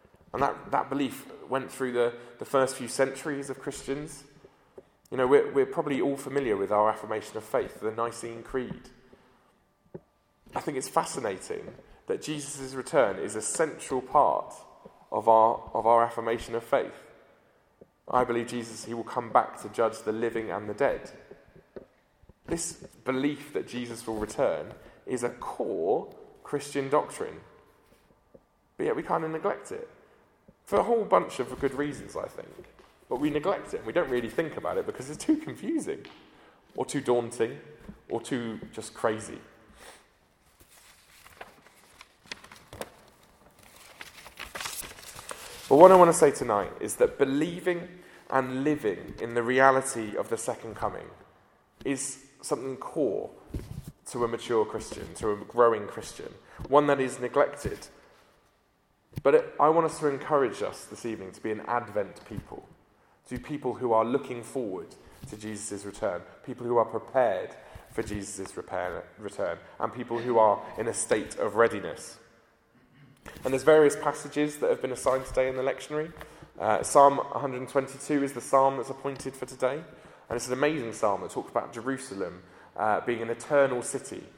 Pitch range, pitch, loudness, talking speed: 115-150 Hz, 130 Hz, -28 LUFS, 155 wpm